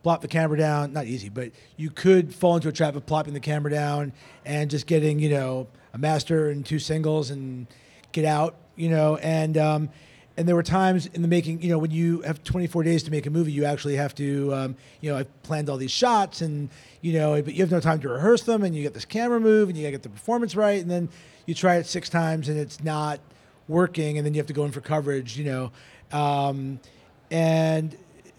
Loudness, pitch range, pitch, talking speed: -25 LUFS, 145-165 Hz, 155 Hz, 240 wpm